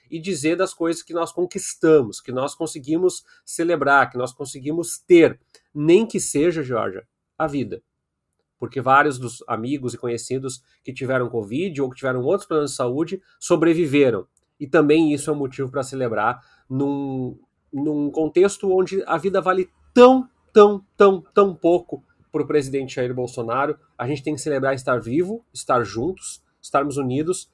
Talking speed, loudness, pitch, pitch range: 160 wpm, -21 LUFS, 150 Hz, 135-180 Hz